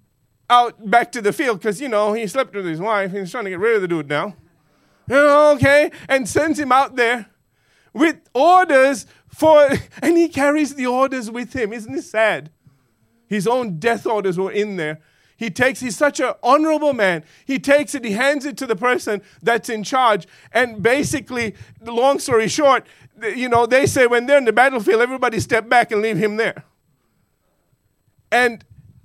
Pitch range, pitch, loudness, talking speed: 205-270 Hz, 235 Hz, -18 LUFS, 185 wpm